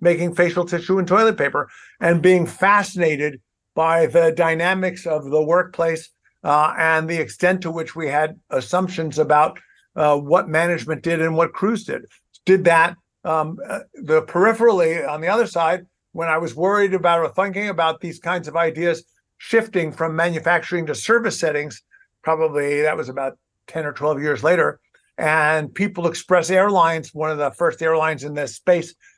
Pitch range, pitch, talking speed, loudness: 155-180 Hz, 165 Hz, 165 wpm, -19 LUFS